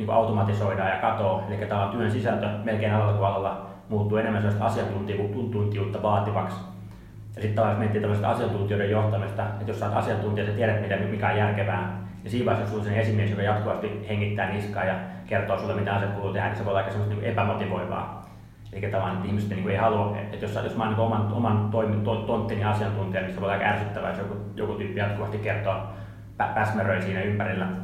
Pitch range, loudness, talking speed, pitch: 100-110 Hz, -26 LUFS, 190 wpm, 105 Hz